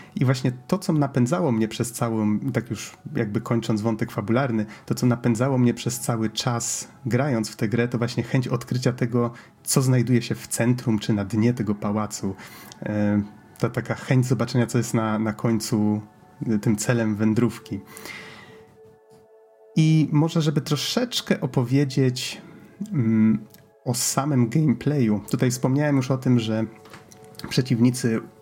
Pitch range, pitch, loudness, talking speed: 110-135 Hz, 120 Hz, -23 LUFS, 145 wpm